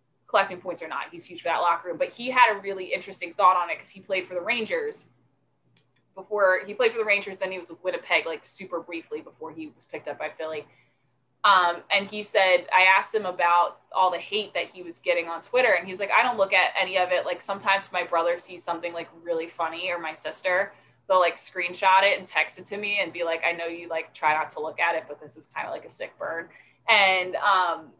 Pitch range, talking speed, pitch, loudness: 165-195 Hz, 255 wpm, 180 Hz, -24 LUFS